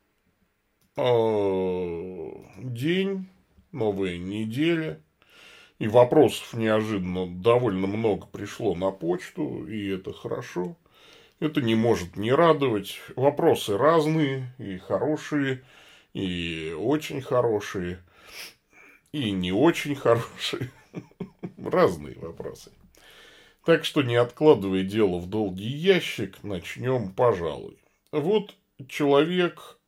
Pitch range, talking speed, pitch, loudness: 95-150 Hz, 90 wpm, 115 Hz, -25 LUFS